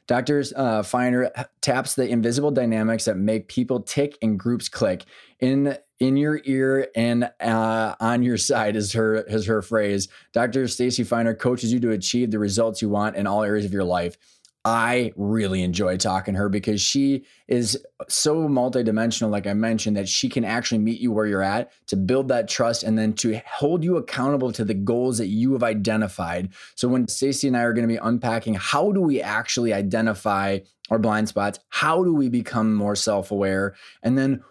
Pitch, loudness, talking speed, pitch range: 115 Hz, -23 LUFS, 195 wpm, 105-125 Hz